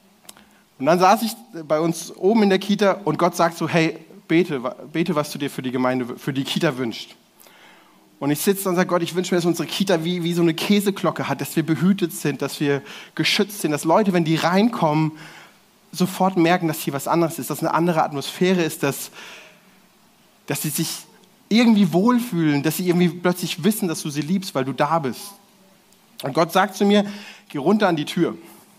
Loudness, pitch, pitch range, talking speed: -21 LUFS, 175 Hz, 155-195 Hz, 205 wpm